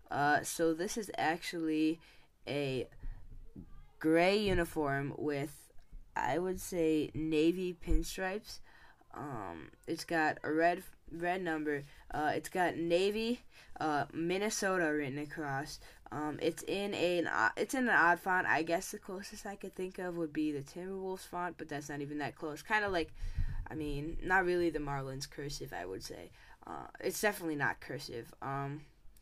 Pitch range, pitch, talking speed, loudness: 145-185 Hz, 160 Hz, 155 wpm, -35 LUFS